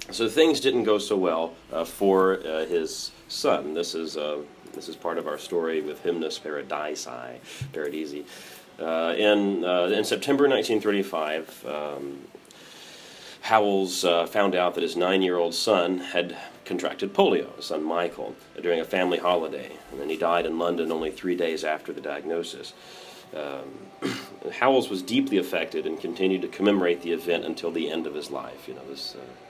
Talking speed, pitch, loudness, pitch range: 165 wpm, 85 Hz, -26 LUFS, 80-100 Hz